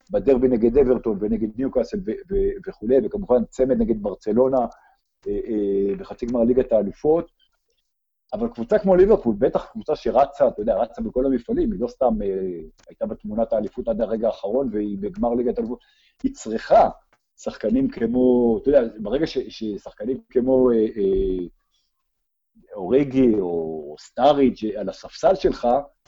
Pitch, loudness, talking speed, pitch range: 125 Hz, -22 LUFS, 130 wpm, 110-150 Hz